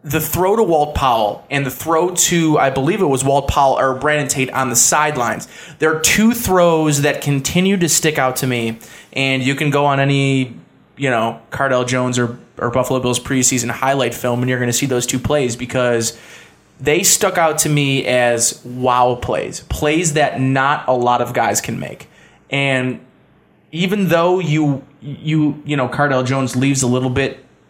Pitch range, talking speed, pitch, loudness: 125-150 Hz, 190 wpm, 135 Hz, -16 LUFS